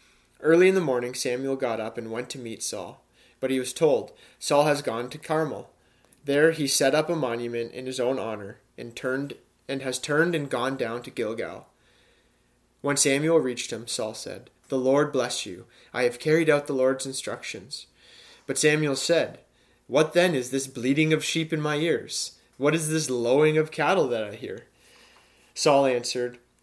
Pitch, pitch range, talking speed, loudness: 135 Hz, 125-155 Hz, 185 wpm, -25 LUFS